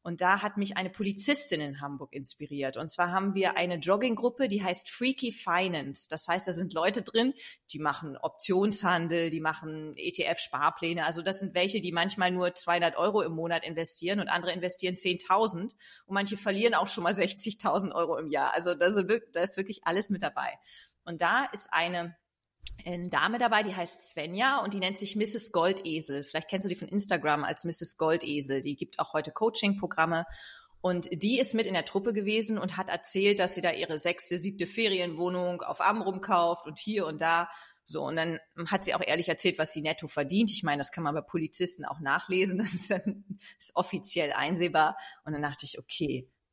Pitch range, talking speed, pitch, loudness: 165-200 Hz, 195 wpm, 180 Hz, -29 LUFS